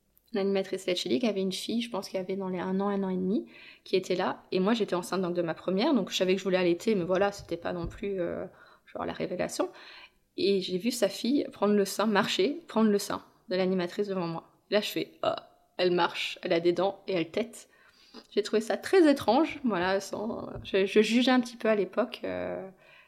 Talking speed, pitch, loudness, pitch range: 235 wpm, 195 Hz, -29 LUFS, 185-215 Hz